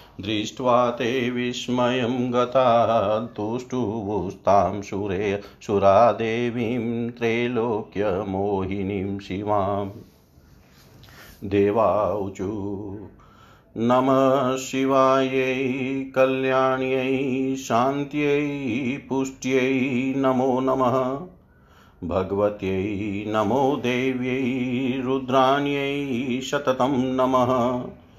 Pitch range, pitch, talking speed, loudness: 105-130 Hz, 125 Hz, 40 wpm, -23 LUFS